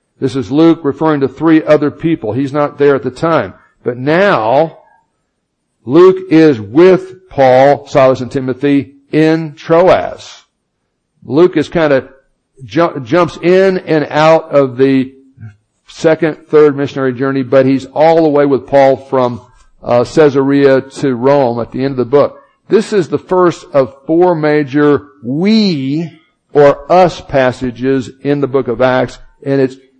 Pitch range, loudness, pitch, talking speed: 135-160 Hz, -11 LUFS, 140 Hz, 150 wpm